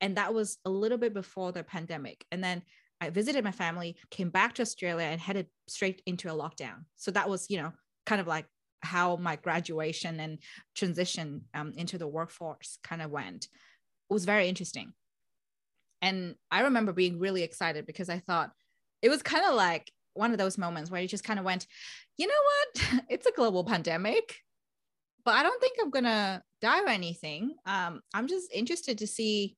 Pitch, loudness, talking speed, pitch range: 185 Hz, -31 LUFS, 195 wpm, 165-210 Hz